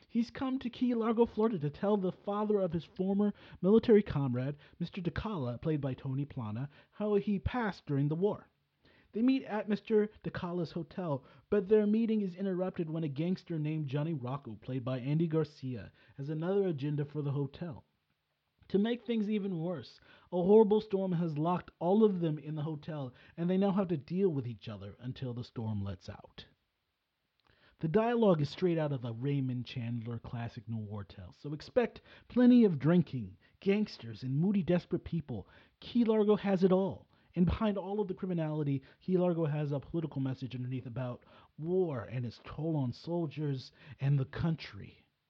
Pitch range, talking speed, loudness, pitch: 130-195 Hz, 180 wpm, -33 LUFS, 160 Hz